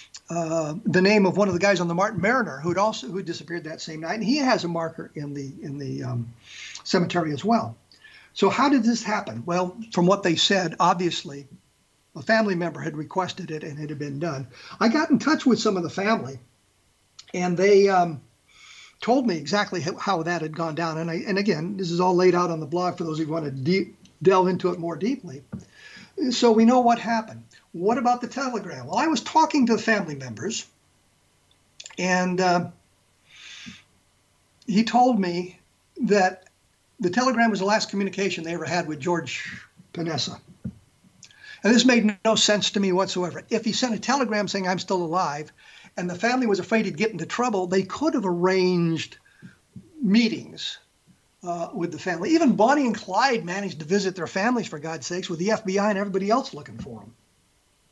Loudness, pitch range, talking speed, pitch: -23 LUFS, 170-220 Hz, 195 wpm, 185 Hz